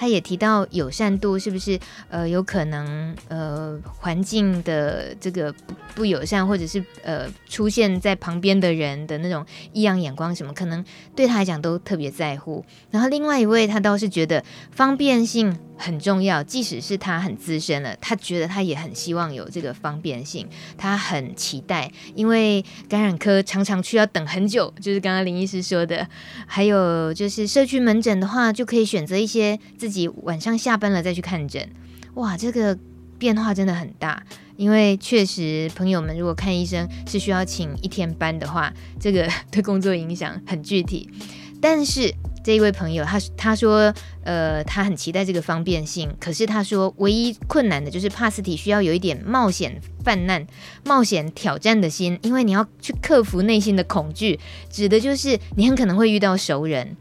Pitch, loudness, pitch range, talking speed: 190 Hz, -22 LUFS, 165-210 Hz, 275 characters per minute